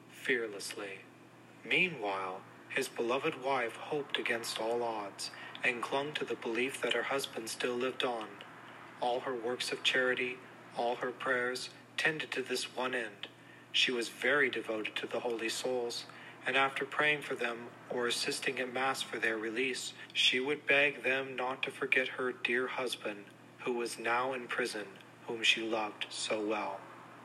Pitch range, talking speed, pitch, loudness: 115-130 Hz, 160 wpm, 125 Hz, -34 LUFS